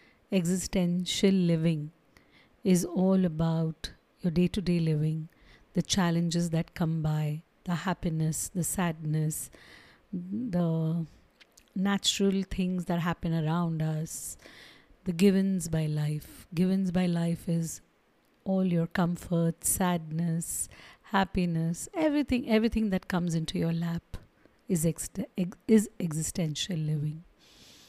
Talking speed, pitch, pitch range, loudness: 105 wpm, 175 Hz, 165-185 Hz, -29 LUFS